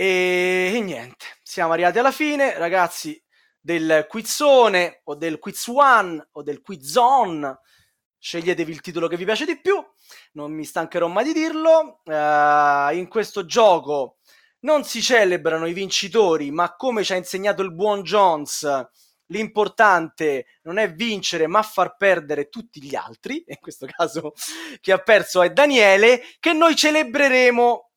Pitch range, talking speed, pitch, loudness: 165-230 Hz, 150 wpm, 190 Hz, -19 LUFS